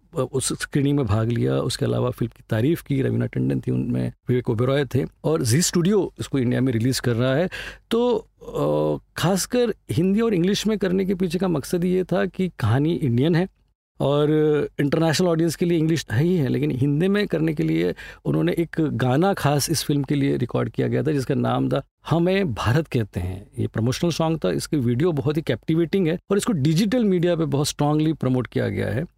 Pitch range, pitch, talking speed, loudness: 125-175 Hz, 150 Hz, 205 wpm, -22 LUFS